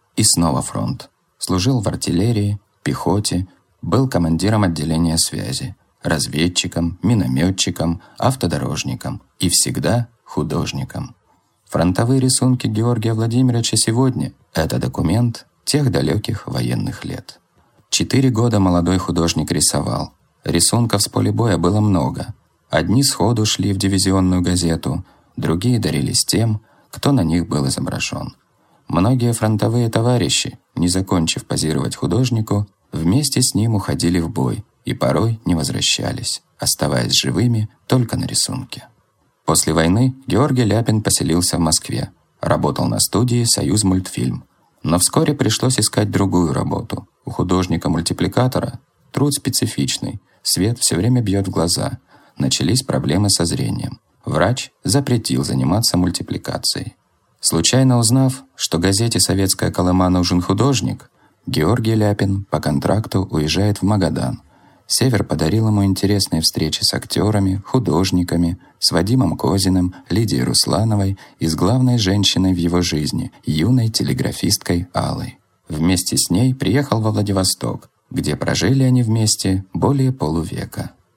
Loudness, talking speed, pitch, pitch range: -18 LUFS, 120 wpm, 100 Hz, 85-120 Hz